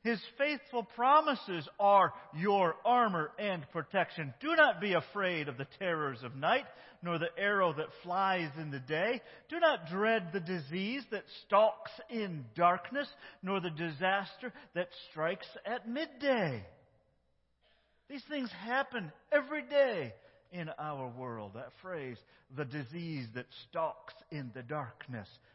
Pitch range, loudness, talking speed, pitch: 155-235 Hz, -34 LUFS, 135 wpm, 185 Hz